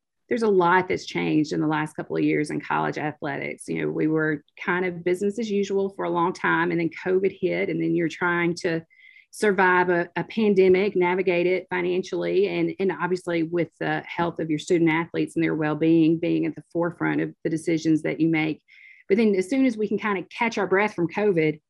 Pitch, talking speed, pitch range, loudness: 175 Hz, 225 wpm, 165-190 Hz, -24 LUFS